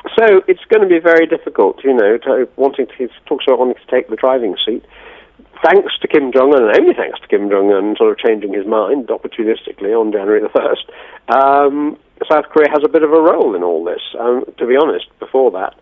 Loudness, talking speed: -13 LUFS, 230 wpm